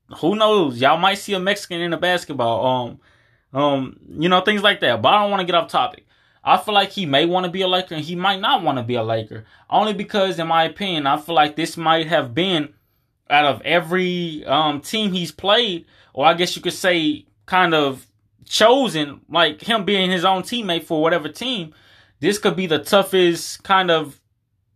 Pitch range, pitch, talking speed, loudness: 140-190 Hz, 165 Hz, 205 wpm, -19 LUFS